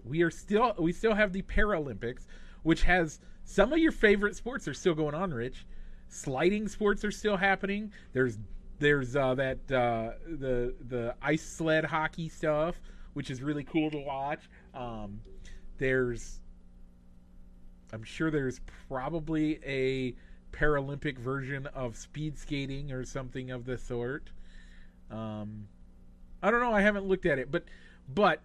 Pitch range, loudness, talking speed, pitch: 115-165 Hz, -31 LUFS, 150 wpm, 135 Hz